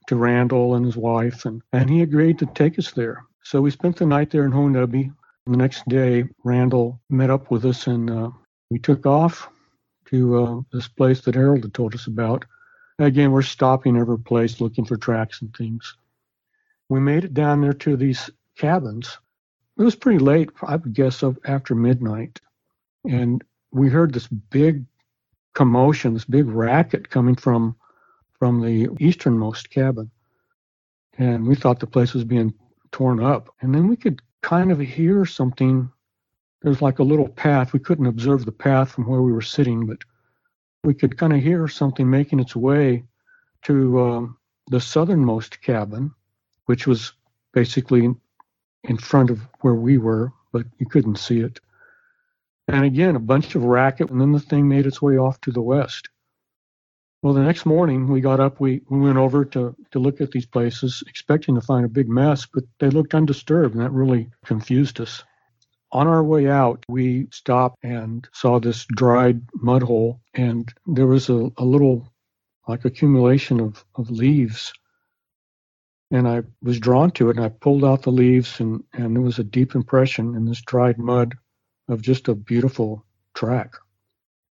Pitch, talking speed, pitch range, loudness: 130 Hz, 175 wpm, 120-140 Hz, -20 LUFS